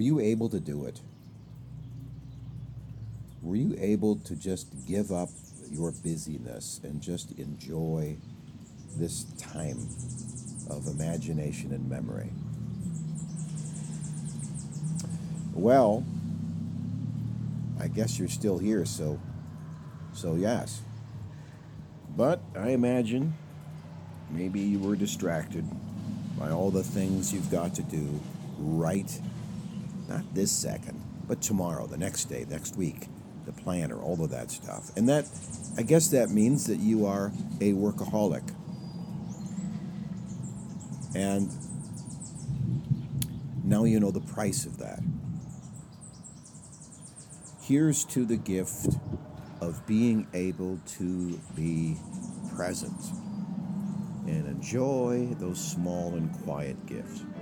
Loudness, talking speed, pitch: -31 LUFS, 110 wpm, 120 Hz